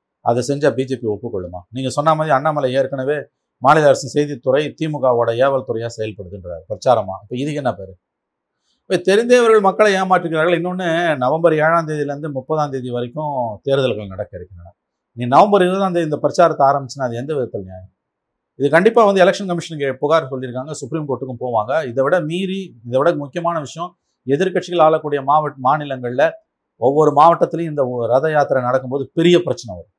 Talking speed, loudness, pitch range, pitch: 150 wpm, -17 LUFS, 130-170 Hz, 145 Hz